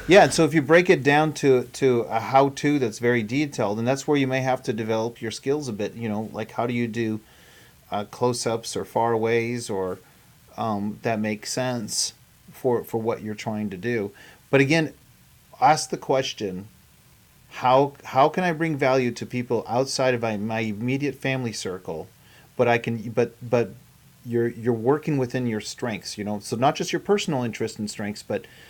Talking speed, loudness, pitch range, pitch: 190 wpm, -24 LUFS, 115-135 Hz, 120 Hz